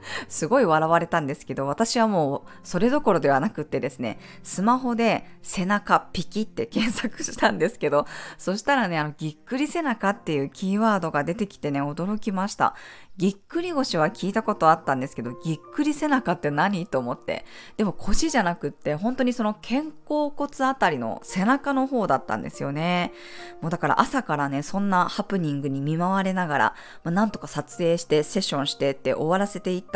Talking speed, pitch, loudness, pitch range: 400 characters per minute, 185 Hz, -25 LUFS, 150-225 Hz